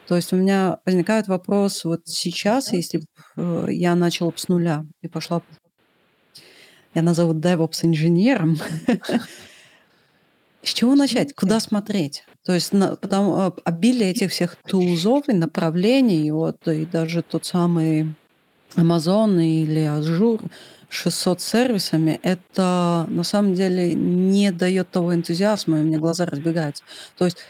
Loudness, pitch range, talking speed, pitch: -21 LUFS, 165-195 Hz, 130 wpm, 175 Hz